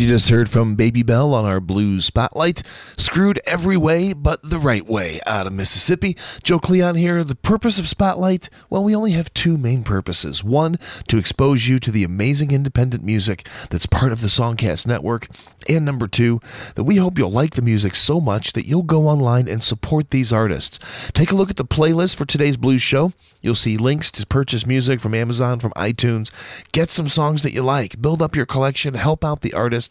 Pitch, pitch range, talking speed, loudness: 130 Hz, 115-155 Hz, 205 wpm, -18 LUFS